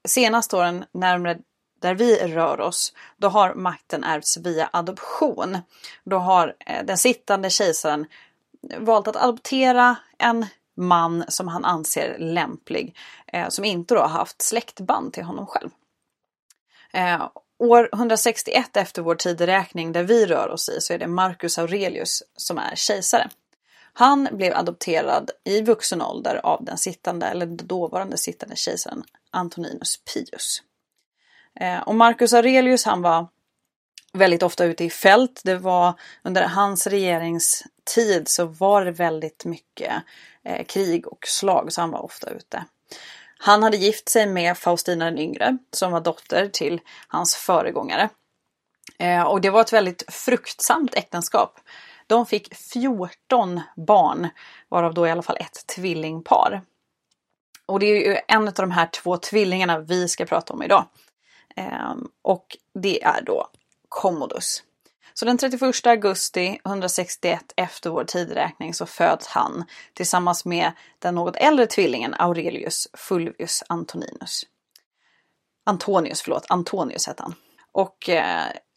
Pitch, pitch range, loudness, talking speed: 185 Hz, 175-225 Hz, -21 LUFS, 135 wpm